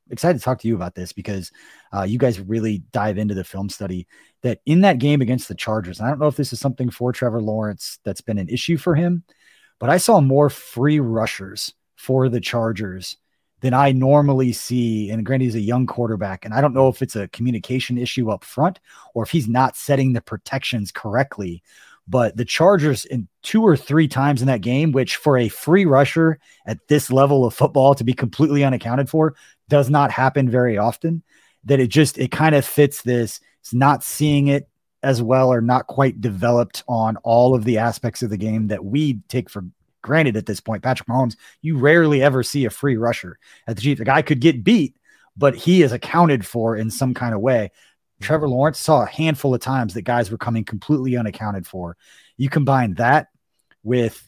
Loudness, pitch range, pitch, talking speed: -19 LUFS, 110-145 Hz, 125 Hz, 210 wpm